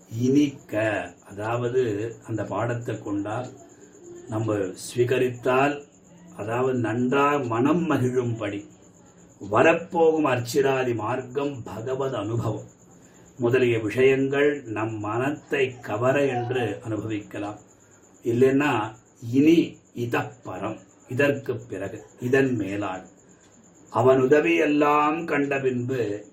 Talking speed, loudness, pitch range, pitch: 80 wpm, -24 LUFS, 110-140 Hz, 125 Hz